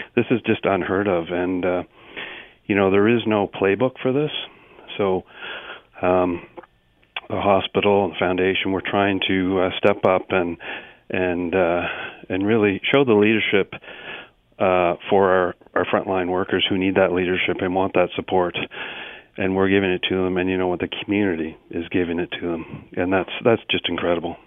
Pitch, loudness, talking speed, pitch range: 95 Hz, -21 LUFS, 175 wpm, 90-100 Hz